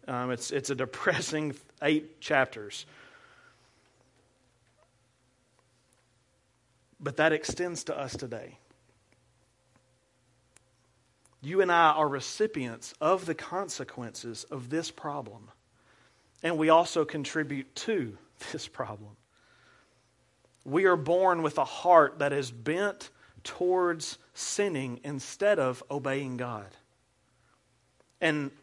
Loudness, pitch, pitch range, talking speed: -29 LUFS, 135 Hz, 125-160 Hz, 100 wpm